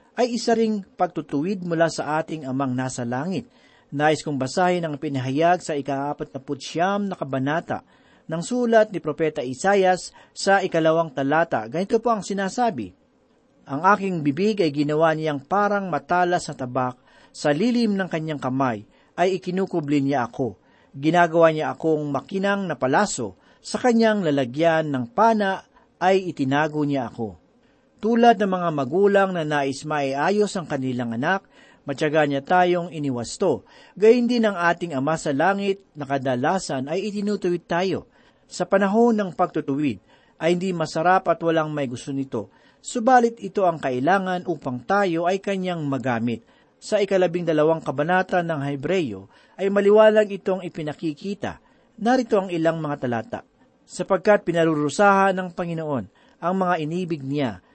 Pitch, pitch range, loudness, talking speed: 170 Hz, 145-195 Hz, -22 LUFS, 140 wpm